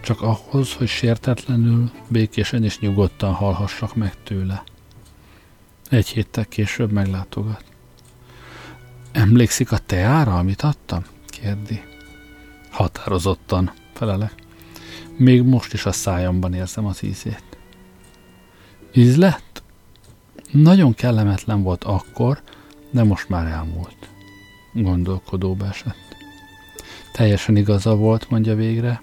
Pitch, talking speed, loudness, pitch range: 105 Hz, 95 wpm, -19 LUFS, 95-120 Hz